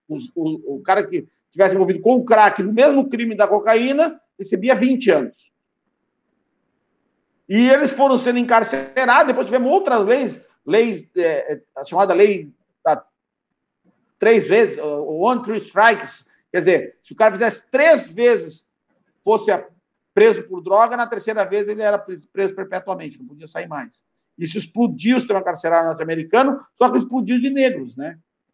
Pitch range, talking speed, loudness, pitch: 190-265 Hz, 160 wpm, -17 LUFS, 230 Hz